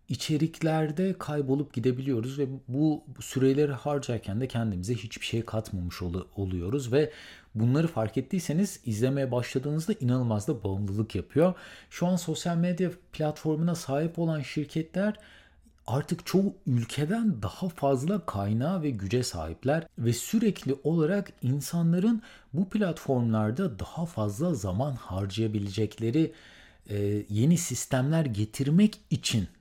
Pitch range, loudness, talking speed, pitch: 115-165 Hz, -29 LUFS, 110 wpm, 140 Hz